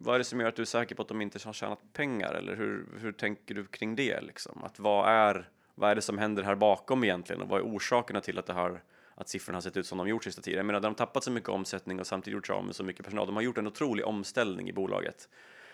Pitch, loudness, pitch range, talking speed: 105 Hz, -32 LUFS, 95-115 Hz, 280 wpm